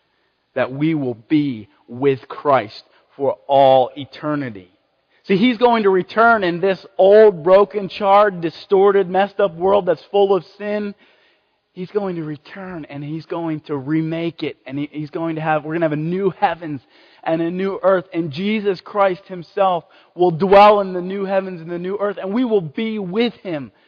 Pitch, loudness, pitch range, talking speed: 185 Hz, -18 LUFS, 155-200 Hz, 185 wpm